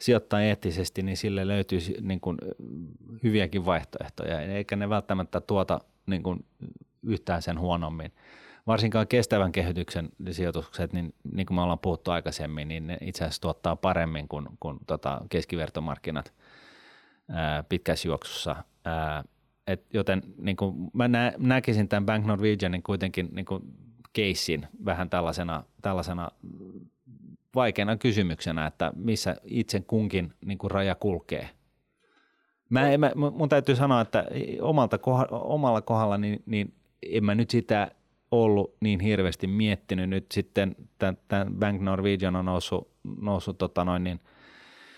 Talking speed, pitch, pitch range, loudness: 135 wpm, 95 Hz, 90-110 Hz, -28 LUFS